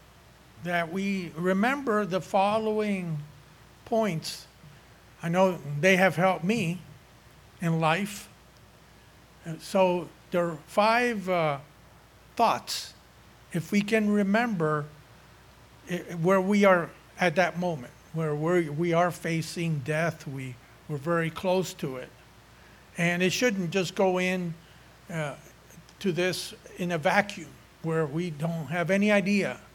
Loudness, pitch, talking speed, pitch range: -27 LUFS, 175 Hz, 120 wpm, 160-190 Hz